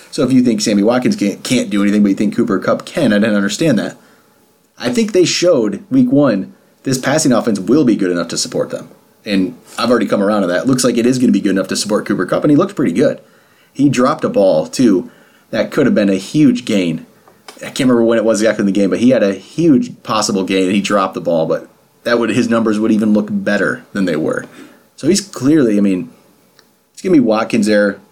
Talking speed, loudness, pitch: 250 wpm, -14 LUFS, 115 Hz